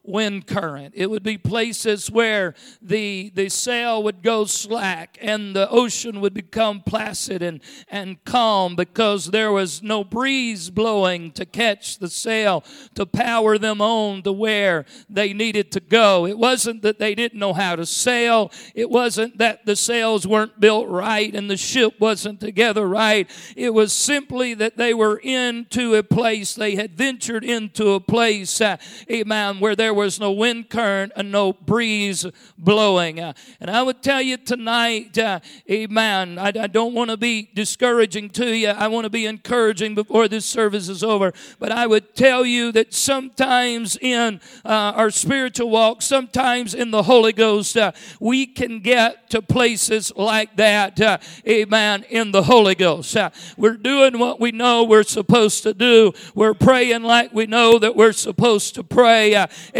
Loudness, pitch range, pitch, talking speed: -18 LUFS, 205-235 Hz, 220 Hz, 175 wpm